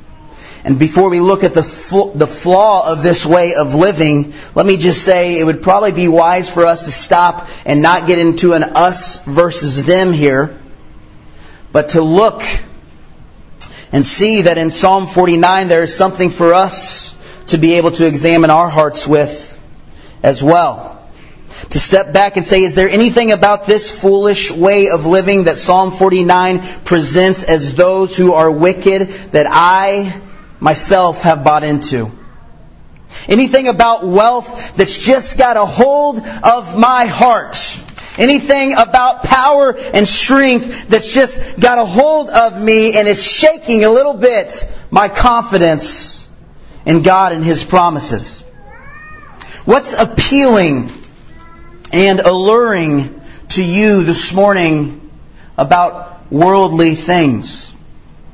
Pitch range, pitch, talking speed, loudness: 160-205 Hz, 180 Hz, 140 wpm, -10 LUFS